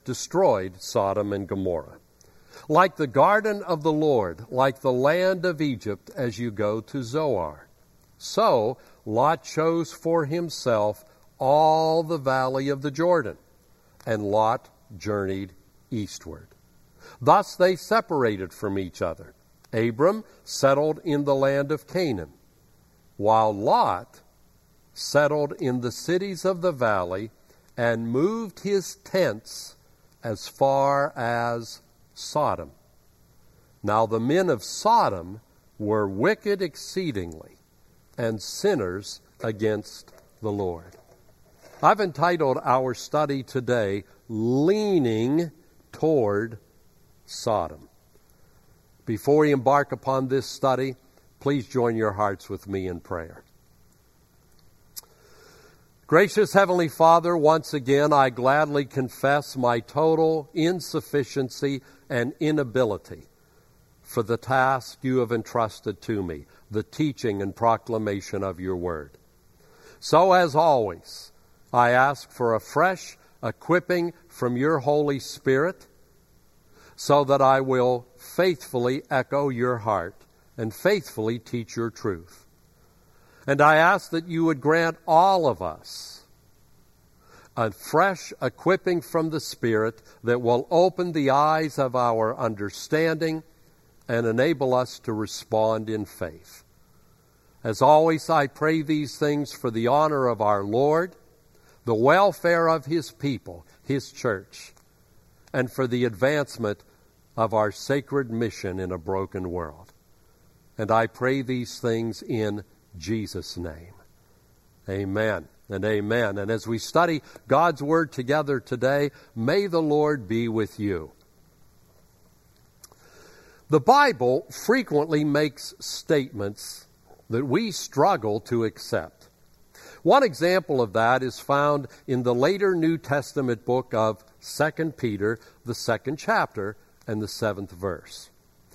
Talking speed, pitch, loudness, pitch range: 120 wpm, 130 Hz, -24 LUFS, 110-155 Hz